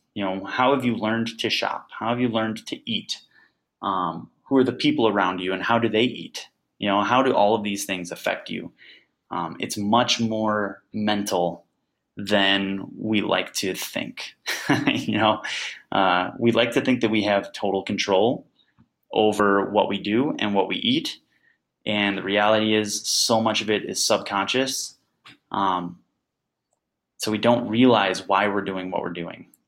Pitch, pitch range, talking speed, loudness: 105 Hz, 100-115 Hz, 175 wpm, -23 LUFS